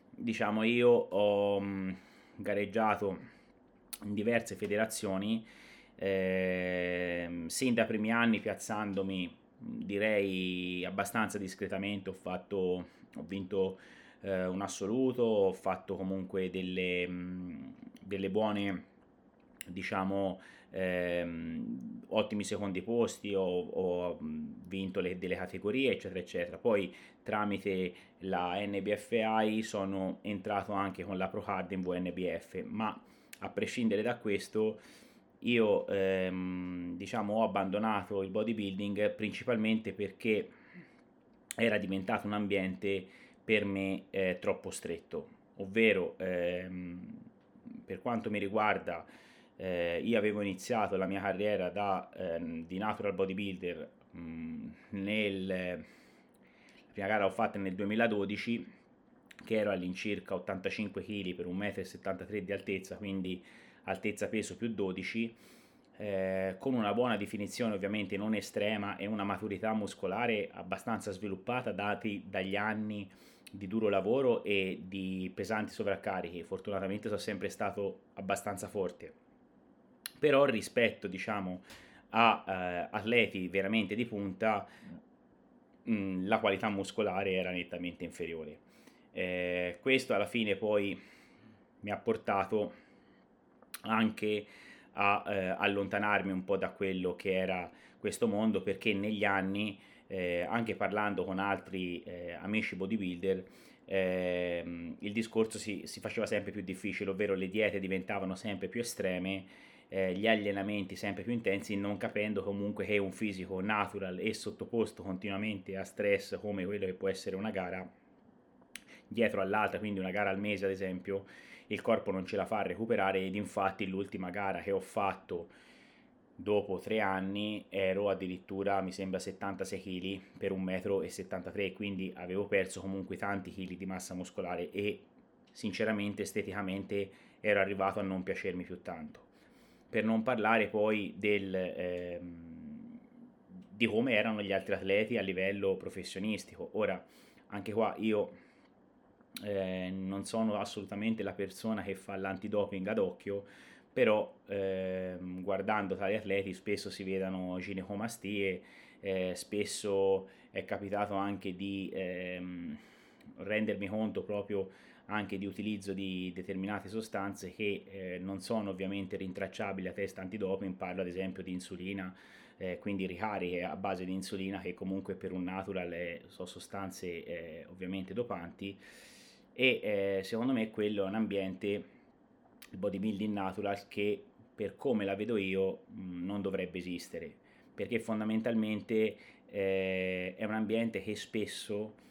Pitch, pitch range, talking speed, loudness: 100 Hz, 95-105 Hz, 125 wpm, -35 LUFS